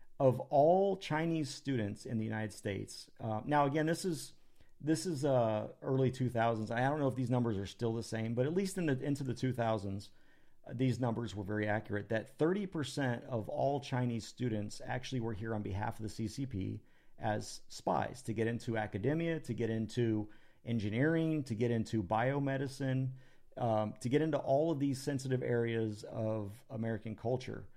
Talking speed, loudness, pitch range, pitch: 175 wpm, -36 LUFS, 110-140 Hz, 120 Hz